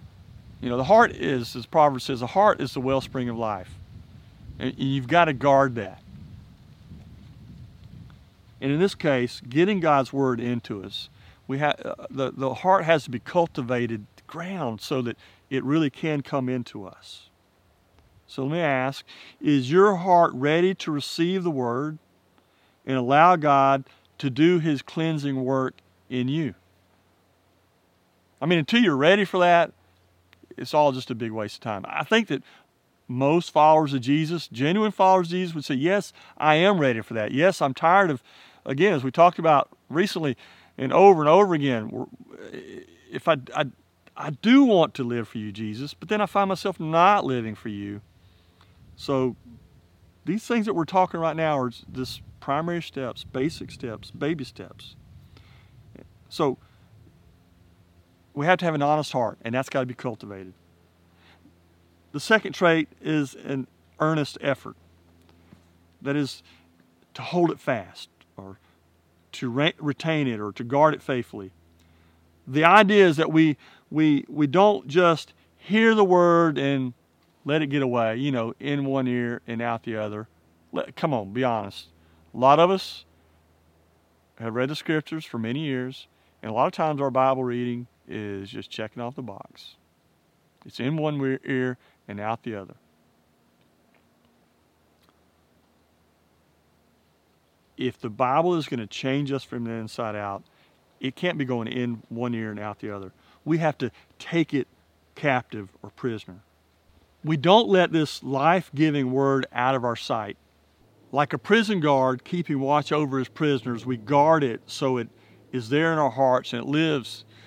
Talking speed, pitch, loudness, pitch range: 165 wpm, 130 Hz, -23 LUFS, 95-150 Hz